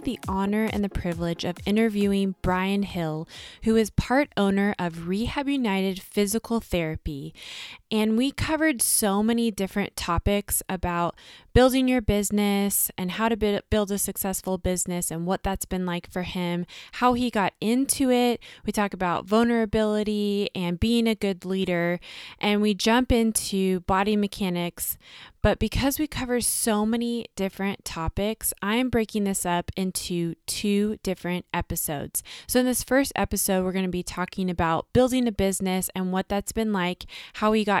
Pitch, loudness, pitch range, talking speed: 200 Hz, -25 LUFS, 185-225 Hz, 160 wpm